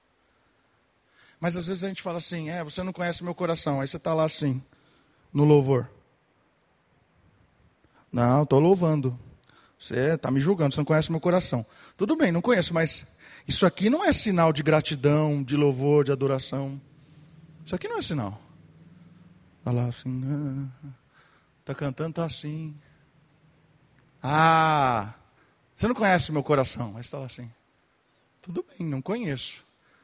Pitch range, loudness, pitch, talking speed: 135-170 Hz, -25 LUFS, 150 Hz, 160 wpm